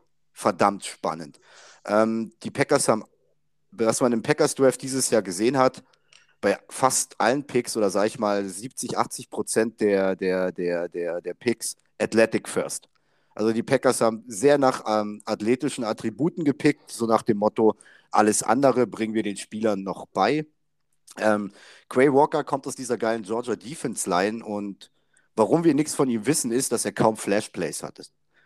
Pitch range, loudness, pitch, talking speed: 105-130 Hz, -24 LUFS, 115 Hz, 170 wpm